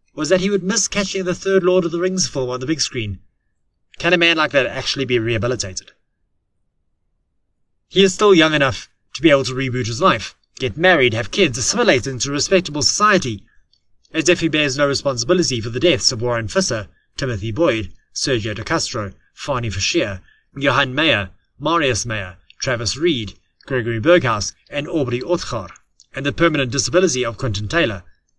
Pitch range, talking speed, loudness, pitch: 115-170 Hz, 175 wpm, -18 LUFS, 130 Hz